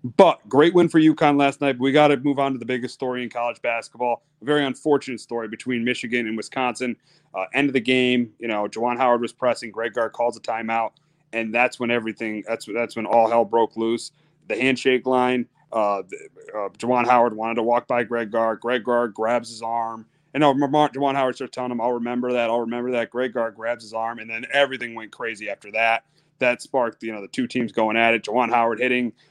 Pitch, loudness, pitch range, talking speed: 120 Hz, -22 LUFS, 115-130 Hz, 225 wpm